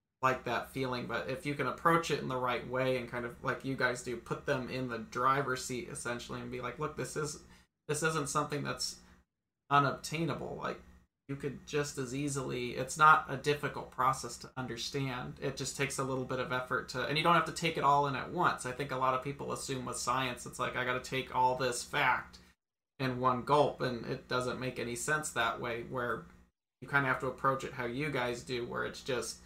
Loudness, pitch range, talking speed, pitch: -34 LUFS, 125-140 Hz, 235 wpm, 130 Hz